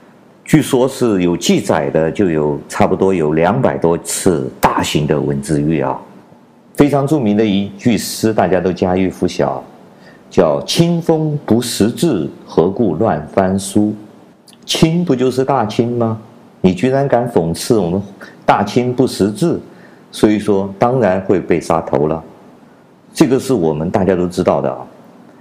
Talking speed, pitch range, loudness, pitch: 215 characters per minute, 90-130 Hz, -15 LUFS, 105 Hz